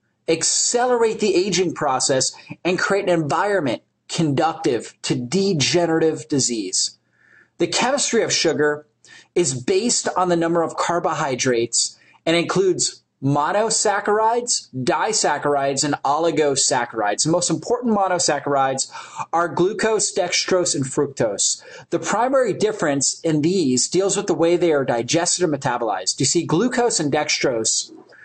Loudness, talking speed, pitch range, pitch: -19 LUFS, 120 wpm, 145-190 Hz, 165 Hz